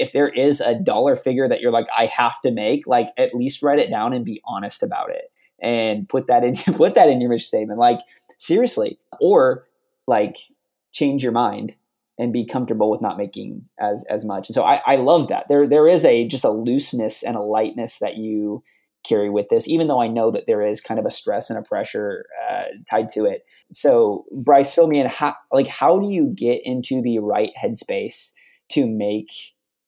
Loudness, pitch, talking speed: -19 LUFS, 130 Hz, 210 wpm